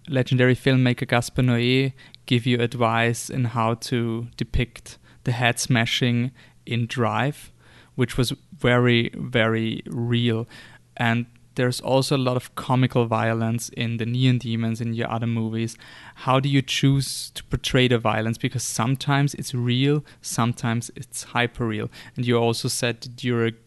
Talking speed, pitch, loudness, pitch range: 150 wpm, 120 Hz, -23 LUFS, 115-130 Hz